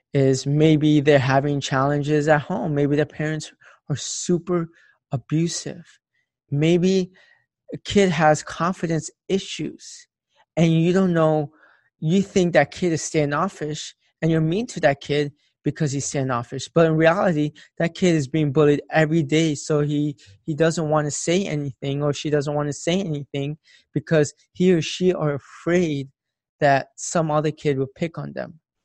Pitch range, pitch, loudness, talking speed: 145-170 Hz, 155 Hz, -22 LUFS, 160 wpm